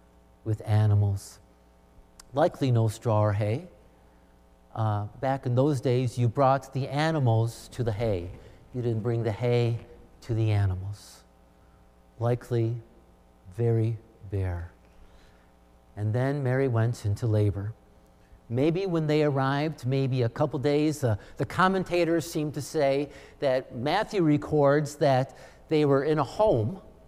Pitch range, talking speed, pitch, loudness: 90-135 Hz, 130 wpm, 115 Hz, -27 LUFS